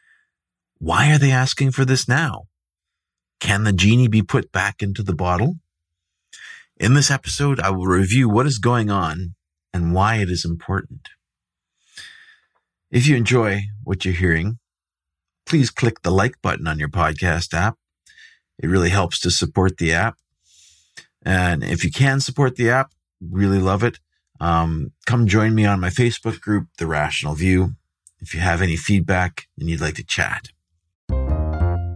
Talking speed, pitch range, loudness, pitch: 160 wpm, 85-120 Hz, -19 LUFS, 95 Hz